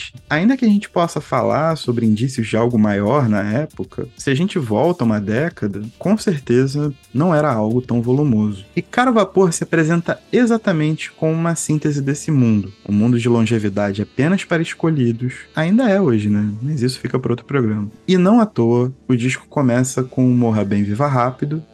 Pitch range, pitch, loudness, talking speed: 115-165 Hz, 130 Hz, -17 LUFS, 180 wpm